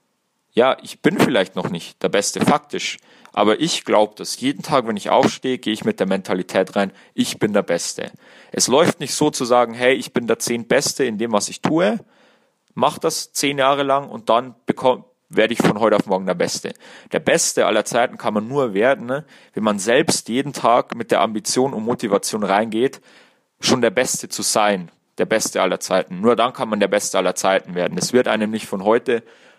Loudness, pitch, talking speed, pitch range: -19 LUFS, 120 Hz, 210 wpm, 105-135 Hz